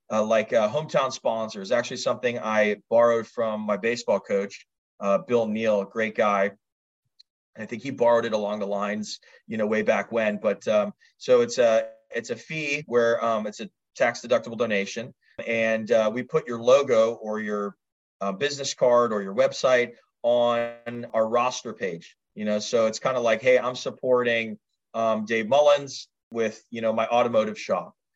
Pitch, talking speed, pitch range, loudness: 115 Hz, 180 wpm, 105-120 Hz, -24 LUFS